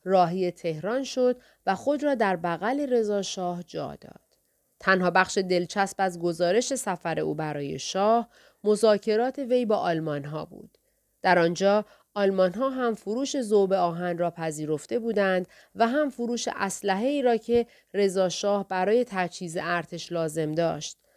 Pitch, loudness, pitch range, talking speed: 195 Hz, -26 LUFS, 175-235 Hz, 145 wpm